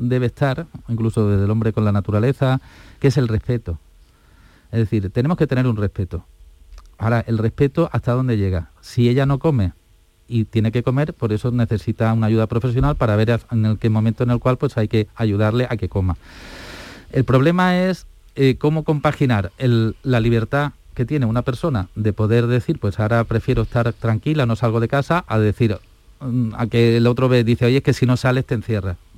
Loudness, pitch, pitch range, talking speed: -19 LUFS, 115 Hz, 110-130 Hz, 195 wpm